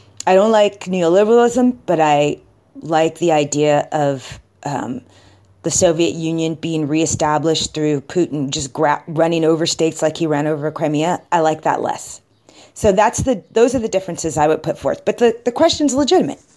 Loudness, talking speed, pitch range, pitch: -17 LUFS, 175 wpm, 150-185 Hz, 160 Hz